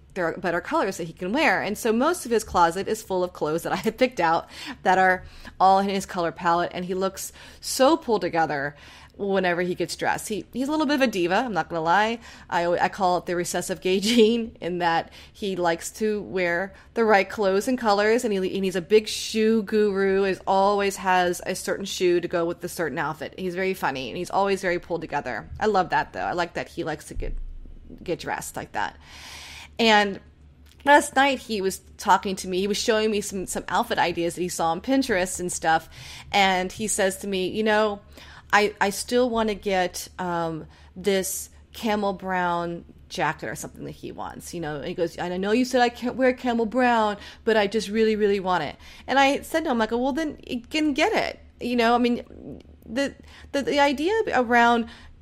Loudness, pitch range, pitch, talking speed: -24 LUFS, 175-225 Hz, 195 Hz, 220 wpm